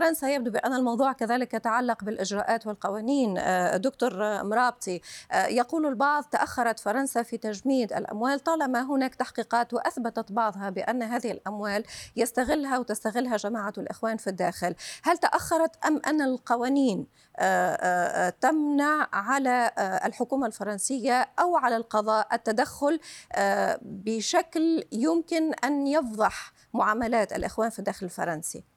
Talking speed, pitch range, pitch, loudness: 110 wpm, 215-275 Hz, 235 Hz, -27 LUFS